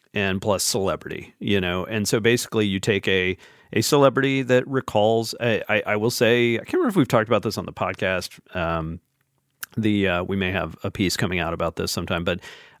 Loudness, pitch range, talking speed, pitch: -22 LUFS, 95-120 Hz, 210 wpm, 110 Hz